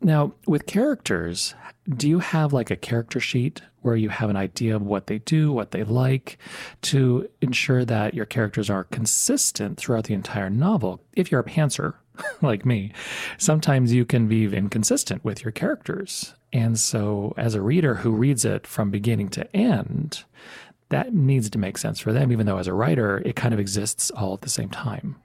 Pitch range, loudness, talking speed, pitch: 105-150 Hz, -23 LUFS, 190 wpm, 120 Hz